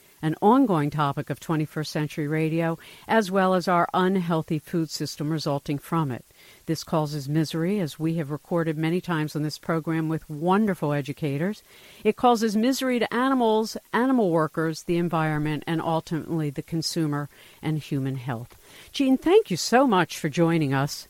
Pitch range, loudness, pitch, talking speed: 150-185 Hz, -25 LUFS, 160 Hz, 160 wpm